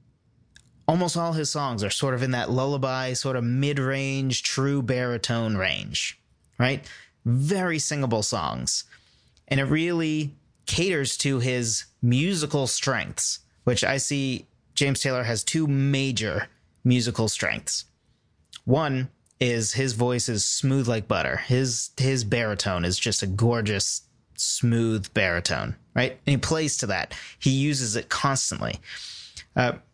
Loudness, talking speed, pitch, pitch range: -25 LUFS, 130 wpm, 125 Hz, 115-140 Hz